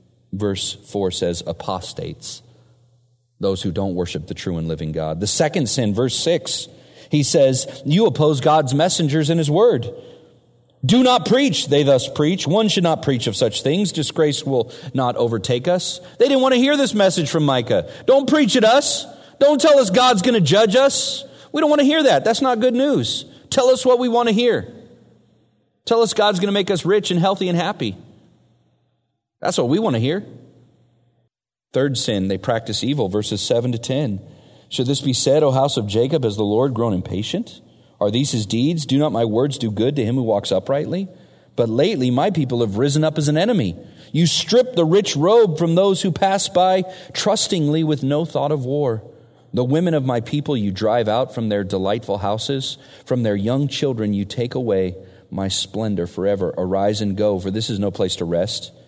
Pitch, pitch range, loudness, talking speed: 140 Hz, 110-185 Hz, -18 LUFS, 200 wpm